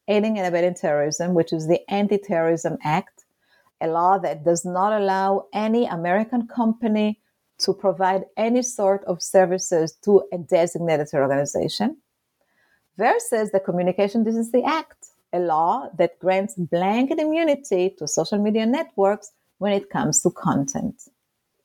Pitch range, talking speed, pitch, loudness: 175-220 Hz, 135 wpm, 195 Hz, -22 LUFS